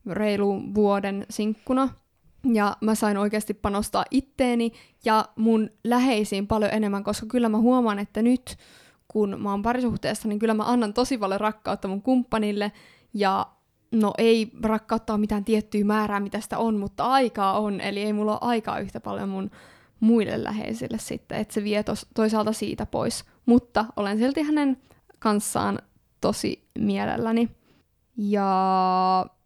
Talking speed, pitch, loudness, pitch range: 145 wpm, 215 Hz, -25 LUFS, 205-230 Hz